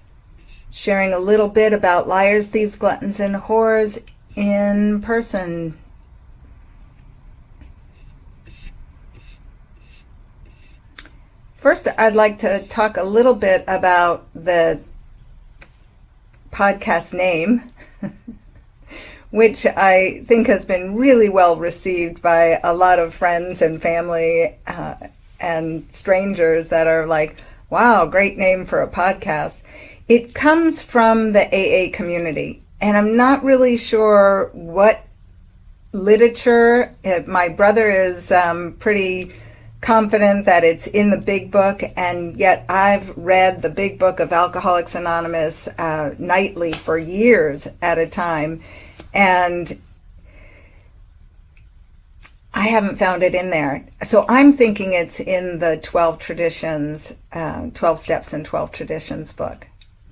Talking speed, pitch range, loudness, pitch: 115 wpm, 165-205 Hz, -17 LUFS, 180 Hz